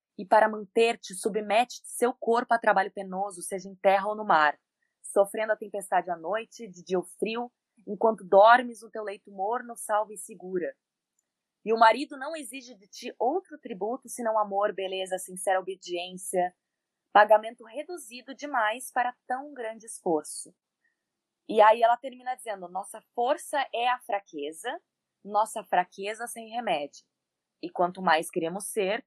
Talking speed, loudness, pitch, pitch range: 150 wpm, -27 LUFS, 215 Hz, 195-240 Hz